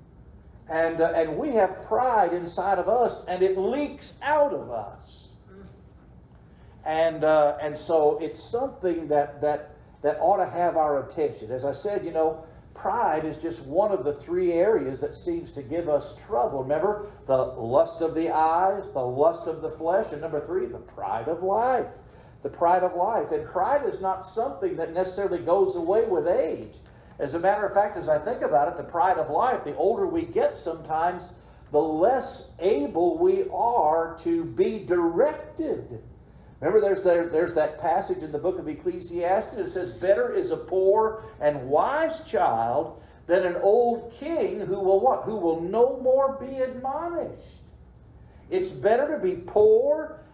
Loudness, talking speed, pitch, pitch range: -25 LUFS, 175 wpm, 175 Hz, 155-235 Hz